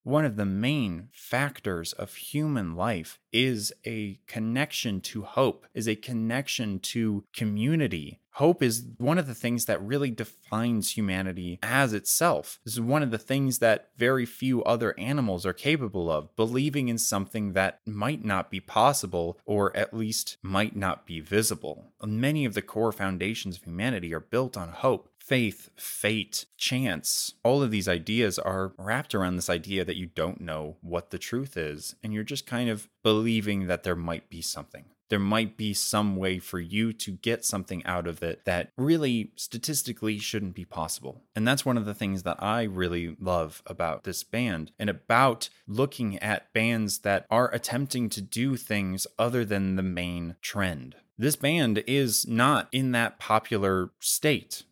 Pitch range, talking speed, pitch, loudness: 95-120 Hz, 170 wpm, 110 Hz, -28 LUFS